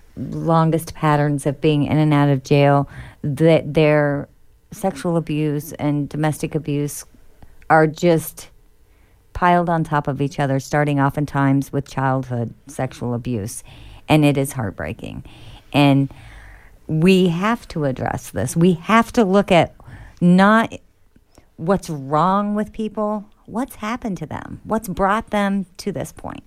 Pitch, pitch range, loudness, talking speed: 150 Hz, 135-175 Hz, -19 LUFS, 135 wpm